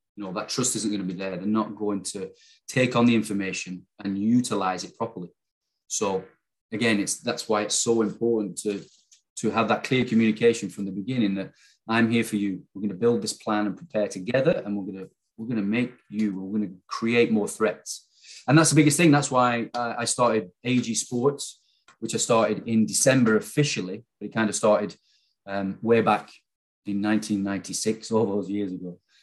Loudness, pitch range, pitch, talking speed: -25 LUFS, 100-120 Hz, 110 Hz, 205 wpm